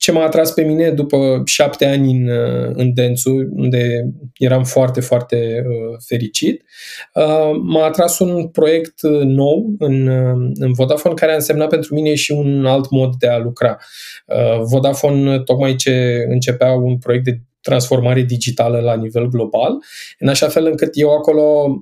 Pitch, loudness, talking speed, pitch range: 130 Hz, -15 LUFS, 150 wpm, 125-150 Hz